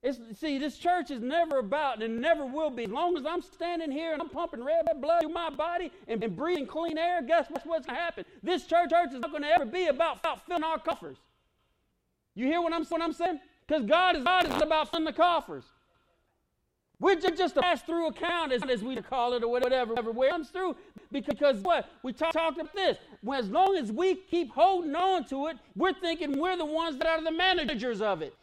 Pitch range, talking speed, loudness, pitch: 280-345 Hz, 230 wpm, -29 LUFS, 325 Hz